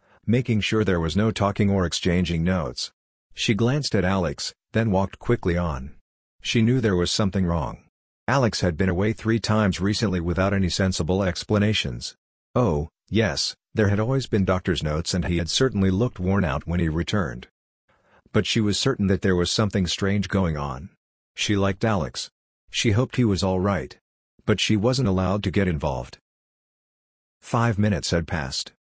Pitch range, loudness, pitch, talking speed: 85-110 Hz, -23 LUFS, 95 Hz, 170 wpm